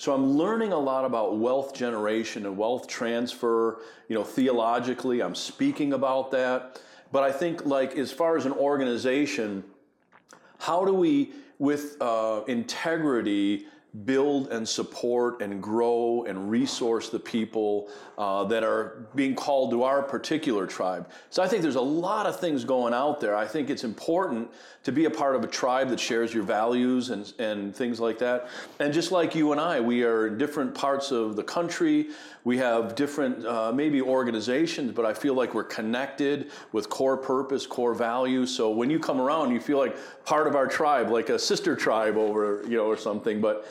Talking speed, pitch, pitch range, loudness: 185 wpm, 125 Hz, 115-145 Hz, -27 LUFS